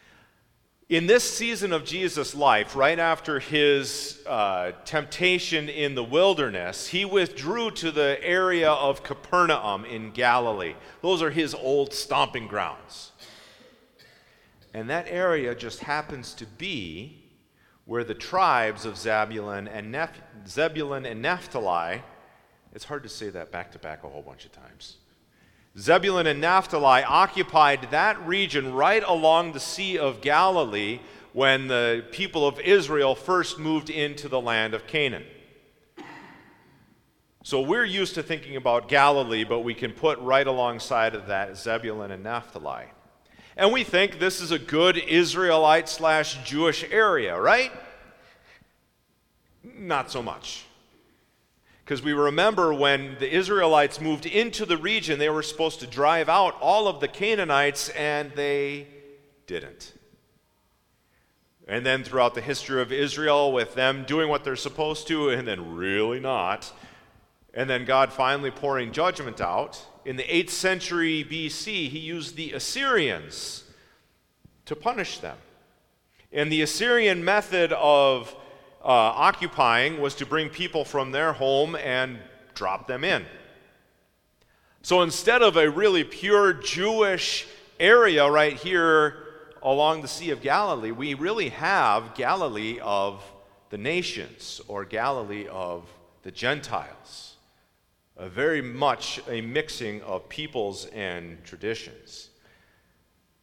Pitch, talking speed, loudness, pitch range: 145 Hz, 135 wpm, -24 LUFS, 125-165 Hz